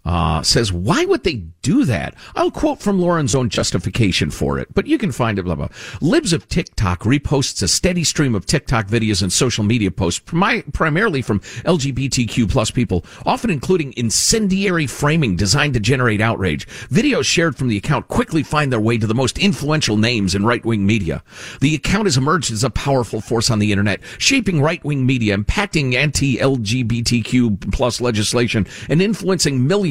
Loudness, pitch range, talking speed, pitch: -17 LUFS, 105-150 Hz, 185 wpm, 125 Hz